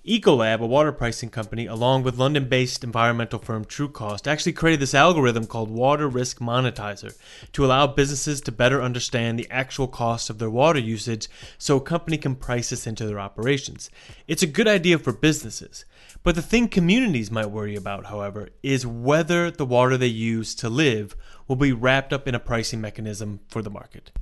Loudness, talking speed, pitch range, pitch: -22 LUFS, 185 wpm, 115-145 Hz, 125 Hz